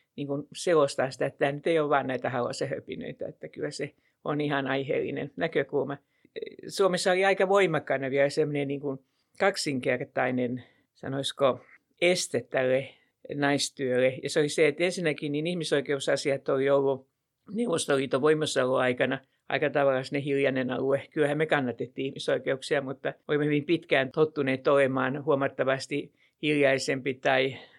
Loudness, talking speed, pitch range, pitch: -27 LUFS, 130 wpm, 135-155 Hz, 140 Hz